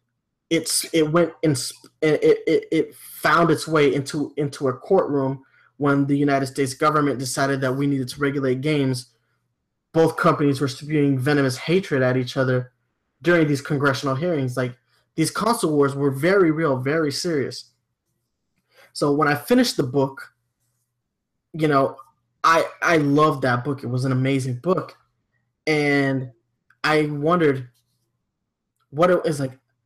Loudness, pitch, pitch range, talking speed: -21 LUFS, 140 Hz, 130-155 Hz, 150 wpm